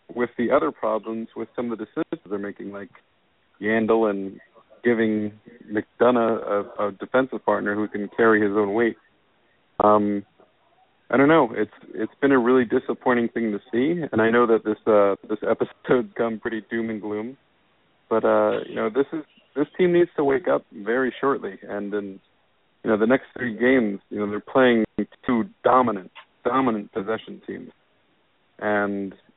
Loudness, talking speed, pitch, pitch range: -23 LUFS, 175 wpm, 110 Hz, 105-120 Hz